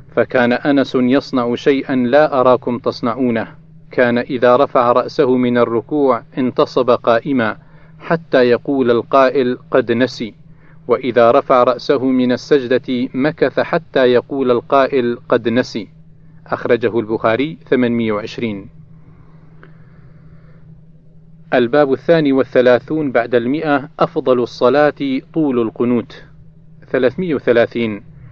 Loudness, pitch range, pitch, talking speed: -15 LUFS, 120-155 Hz, 130 Hz, 95 wpm